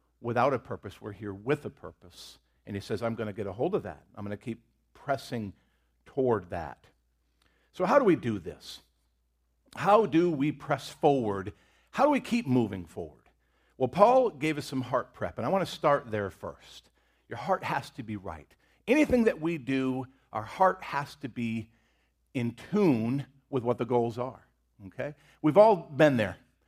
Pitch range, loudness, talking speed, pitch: 100-145 Hz, -29 LUFS, 190 wpm, 125 Hz